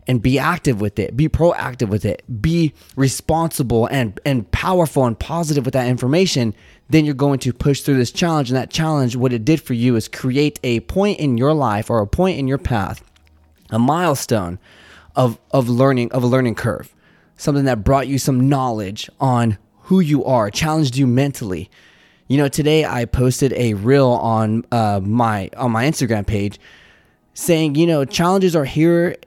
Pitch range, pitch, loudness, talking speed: 115-150 Hz, 130 Hz, -18 LUFS, 185 wpm